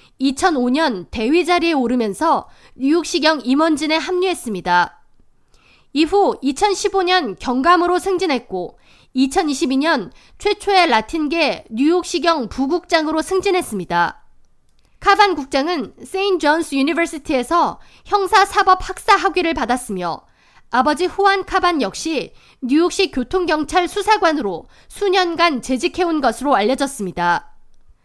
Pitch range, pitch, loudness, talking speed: 265-370 Hz, 325 Hz, -17 LUFS, 265 characters per minute